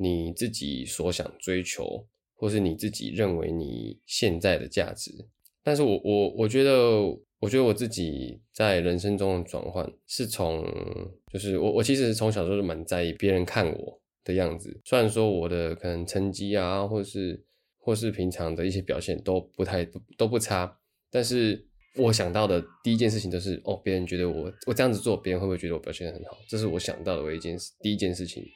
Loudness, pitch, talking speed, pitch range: -28 LUFS, 95 Hz, 300 characters per minute, 90-110 Hz